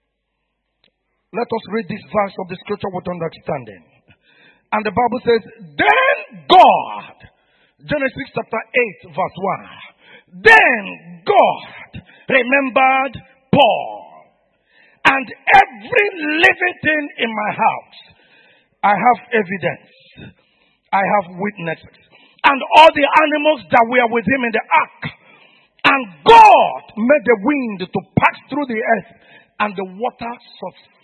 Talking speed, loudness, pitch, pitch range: 120 wpm, -15 LUFS, 235 Hz, 205-280 Hz